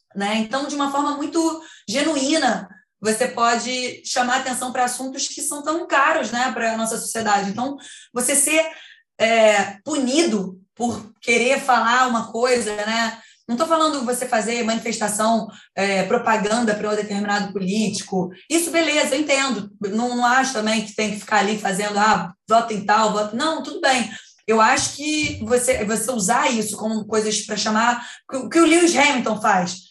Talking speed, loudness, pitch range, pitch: 165 wpm, -20 LUFS, 215-275 Hz, 235 Hz